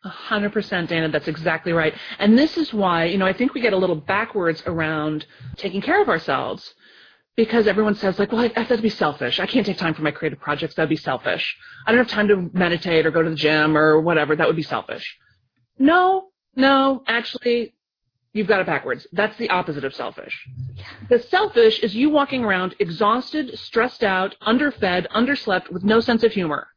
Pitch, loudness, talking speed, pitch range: 195 Hz, -20 LUFS, 205 wpm, 160-235 Hz